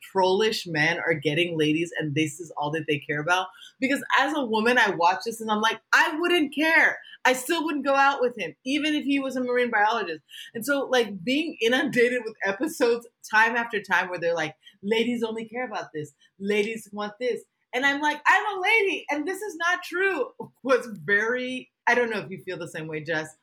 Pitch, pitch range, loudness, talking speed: 235 Hz, 185-280 Hz, -24 LUFS, 215 wpm